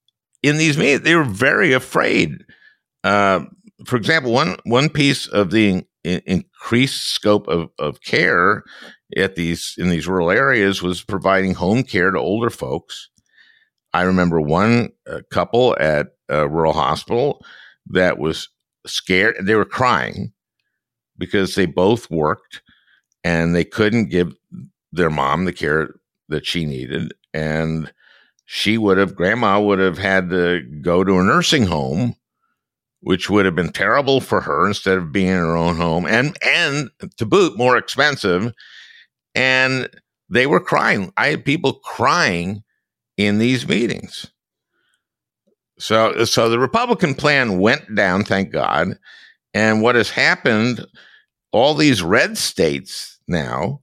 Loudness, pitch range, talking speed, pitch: -17 LUFS, 90-115 Hz, 145 wpm, 100 Hz